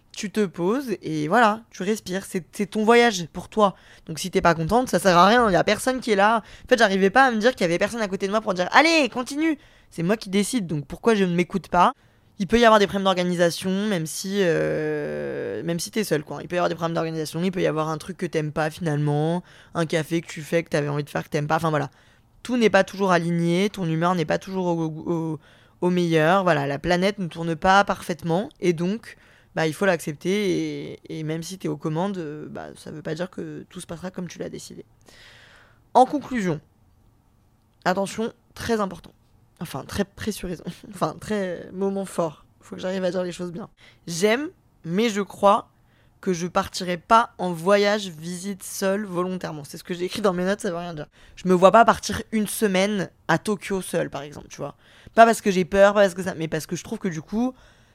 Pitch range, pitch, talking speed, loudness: 160-205 Hz, 180 Hz, 235 wpm, -23 LUFS